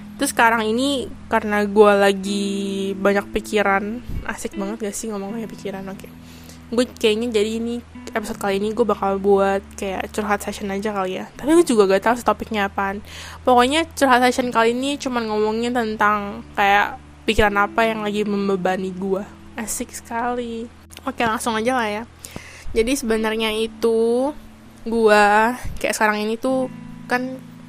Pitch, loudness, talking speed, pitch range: 220 Hz, -20 LUFS, 155 wpm, 200-235 Hz